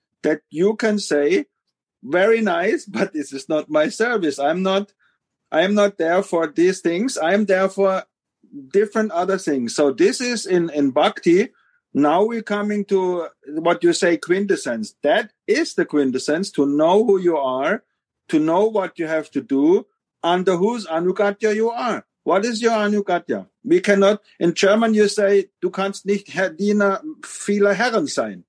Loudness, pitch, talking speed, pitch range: -19 LUFS, 200 Hz, 165 wpm, 170-220 Hz